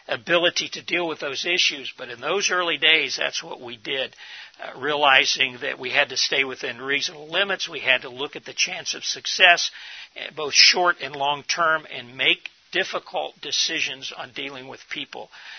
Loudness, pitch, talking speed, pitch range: -21 LUFS, 155 Hz, 175 wpm, 140-175 Hz